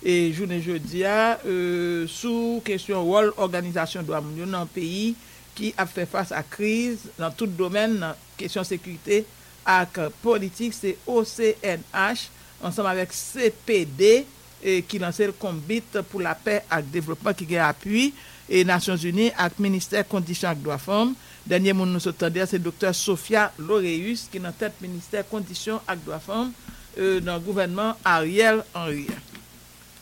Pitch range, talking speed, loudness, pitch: 175-210 Hz, 145 wpm, -24 LUFS, 190 Hz